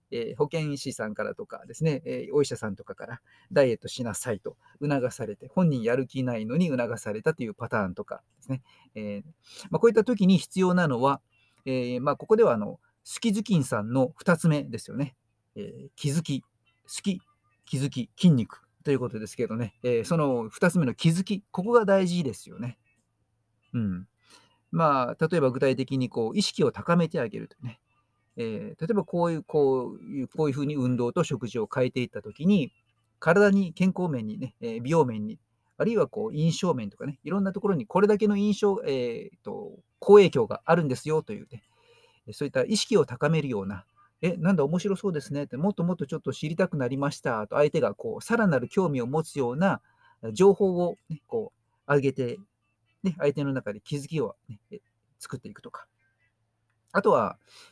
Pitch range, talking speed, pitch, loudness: 120-180 Hz, 365 characters per minute, 140 Hz, -27 LUFS